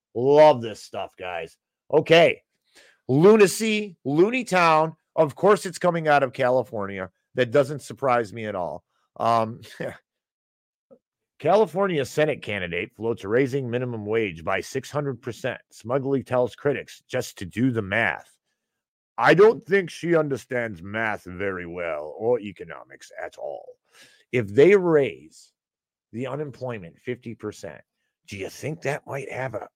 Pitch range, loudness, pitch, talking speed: 115-155 Hz, -23 LUFS, 130 Hz, 130 wpm